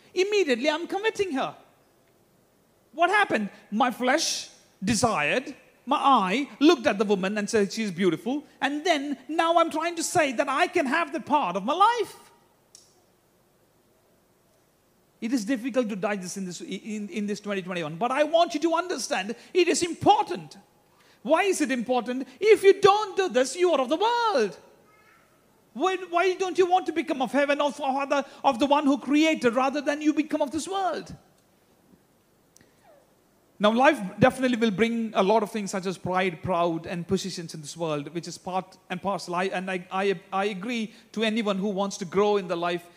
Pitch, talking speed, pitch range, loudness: 260 Hz, 180 wpm, 200-320 Hz, -25 LUFS